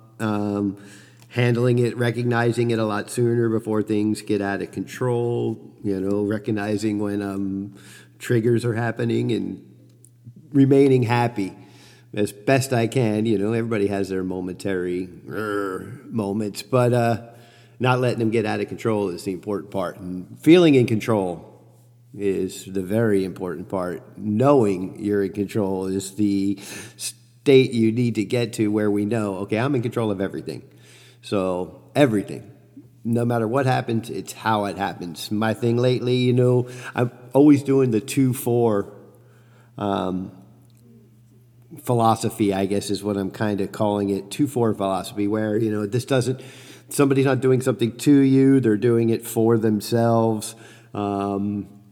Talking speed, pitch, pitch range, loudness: 155 wpm, 110 Hz, 100-120 Hz, -22 LUFS